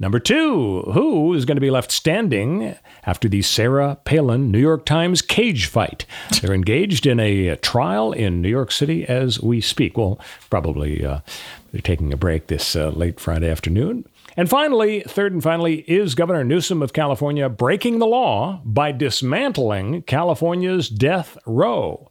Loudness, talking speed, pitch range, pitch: -19 LUFS, 165 wpm, 105-165 Hz, 135 Hz